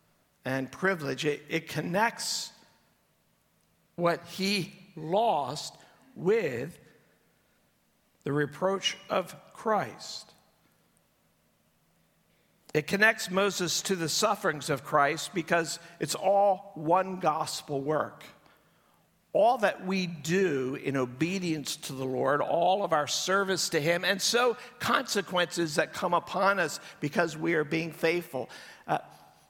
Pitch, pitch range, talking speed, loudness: 170 Hz, 155-195 Hz, 110 wpm, -29 LUFS